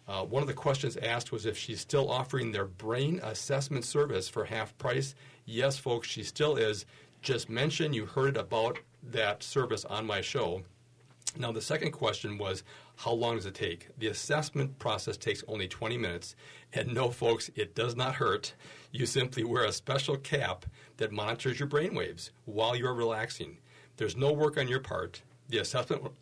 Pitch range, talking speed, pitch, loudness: 110-140 Hz, 180 wpm, 125 Hz, -33 LUFS